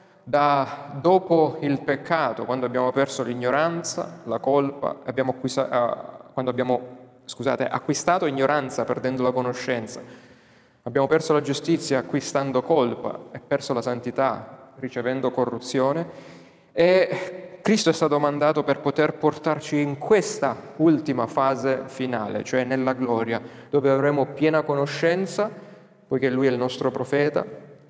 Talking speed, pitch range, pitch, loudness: 125 wpm, 130-150 Hz, 135 Hz, -23 LUFS